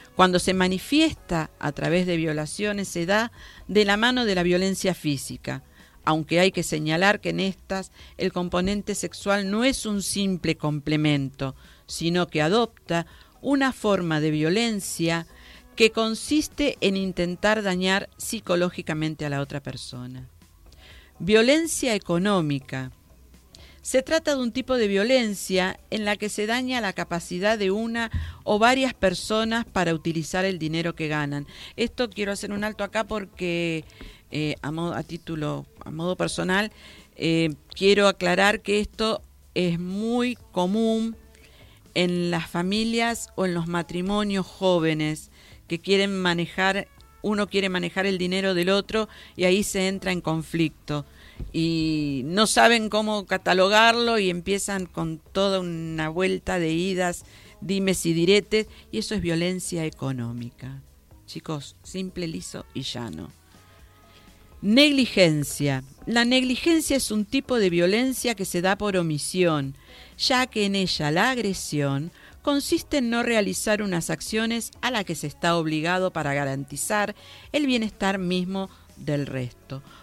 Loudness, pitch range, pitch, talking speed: -24 LUFS, 160-210 Hz, 185 Hz, 140 wpm